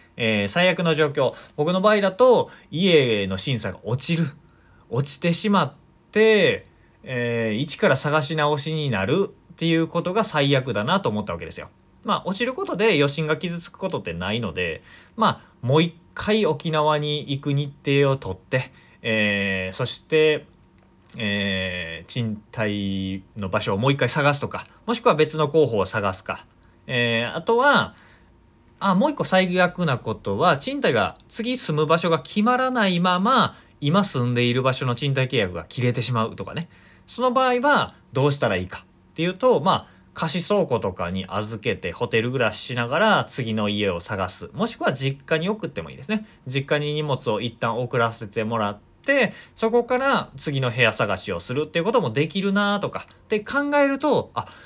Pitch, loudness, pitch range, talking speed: 145 Hz, -22 LUFS, 115-180 Hz, 330 characters per minute